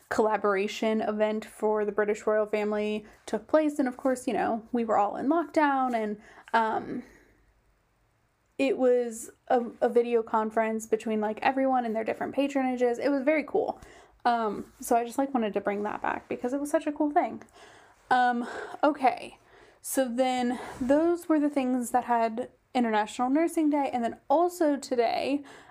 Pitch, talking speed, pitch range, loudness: 245 Hz, 170 wpm, 215-275 Hz, -28 LUFS